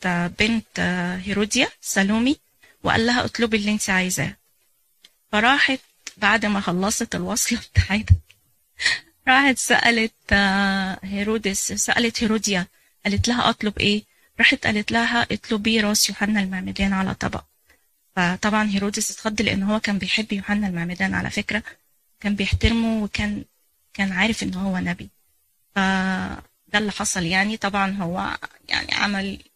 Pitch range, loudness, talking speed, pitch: 190-220 Hz, -21 LUFS, 120 wpm, 205 Hz